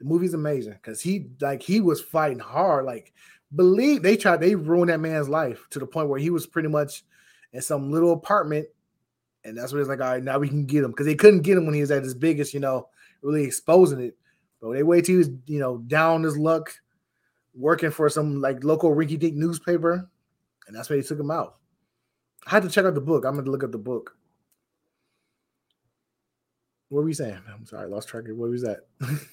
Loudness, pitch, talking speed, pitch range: -23 LUFS, 150 Hz, 225 wpm, 135-165 Hz